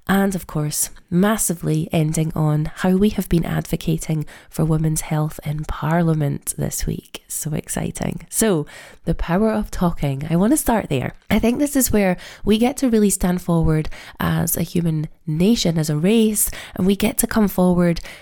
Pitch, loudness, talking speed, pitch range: 175 Hz, -20 LUFS, 180 wpm, 160-205 Hz